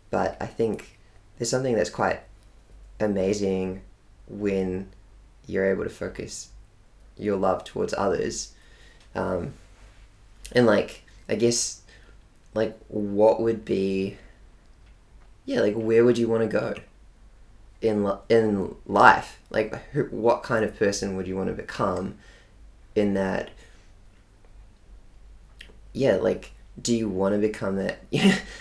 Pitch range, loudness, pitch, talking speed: 95-110 Hz, -25 LUFS, 105 Hz, 125 wpm